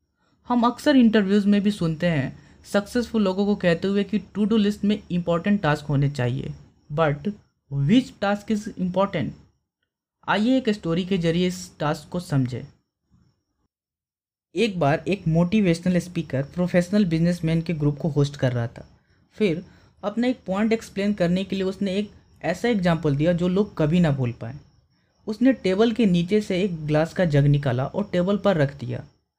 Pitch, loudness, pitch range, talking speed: 180 Hz, -23 LUFS, 150-205 Hz, 170 wpm